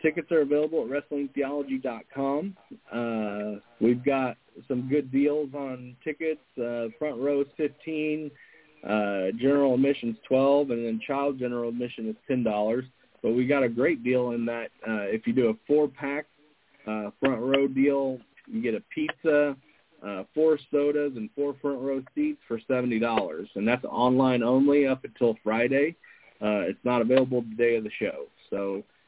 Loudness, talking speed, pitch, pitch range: -27 LUFS, 165 wpm, 135 Hz, 115-145 Hz